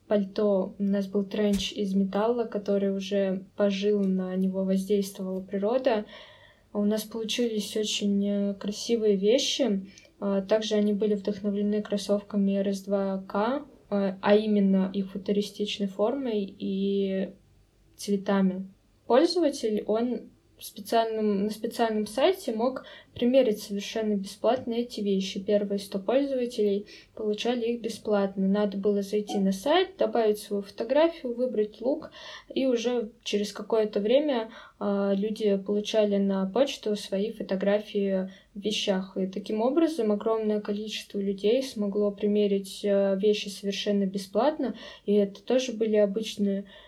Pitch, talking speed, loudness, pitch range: 210 Hz, 115 wpm, -27 LUFS, 200-225 Hz